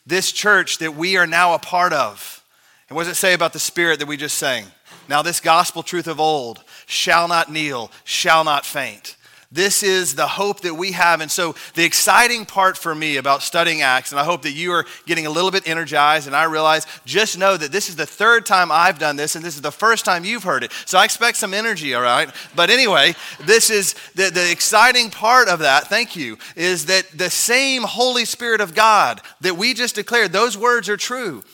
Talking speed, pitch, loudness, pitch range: 225 wpm, 175 Hz, -16 LUFS, 160-205 Hz